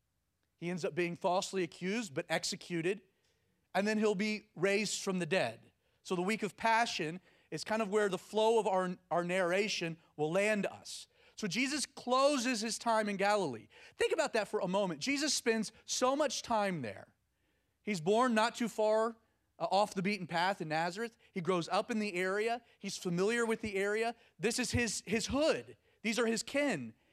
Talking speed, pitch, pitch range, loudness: 185 wpm, 205 Hz, 180-225 Hz, -34 LUFS